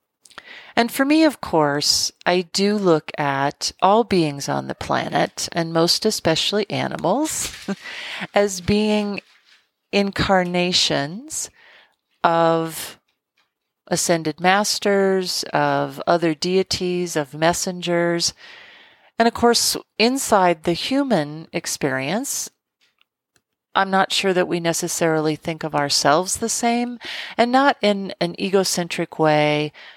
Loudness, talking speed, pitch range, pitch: -20 LUFS, 105 wpm, 165-210 Hz, 180 Hz